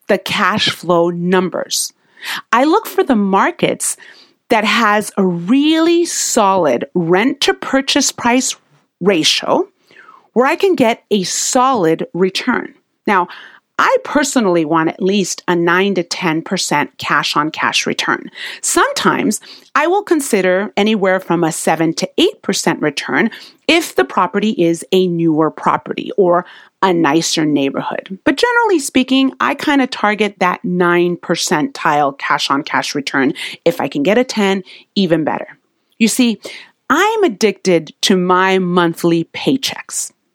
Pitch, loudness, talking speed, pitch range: 195 Hz, -15 LUFS, 135 wpm, 175-270 Hz